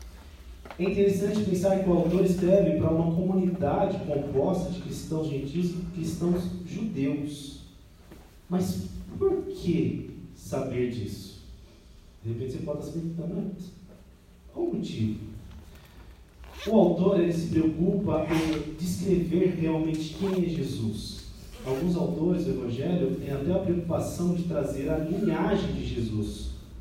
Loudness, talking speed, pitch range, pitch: -28 LUFS, 135 wpm, 135-185 Hz, 165 Hz